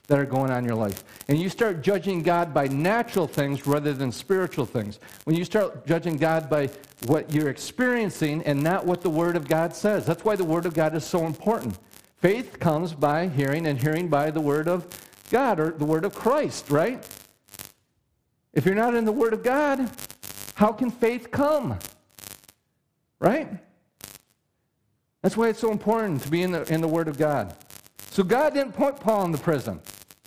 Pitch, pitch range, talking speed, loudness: 165 Hz, 145-205 Hz, 190 wpm, -25 LUFS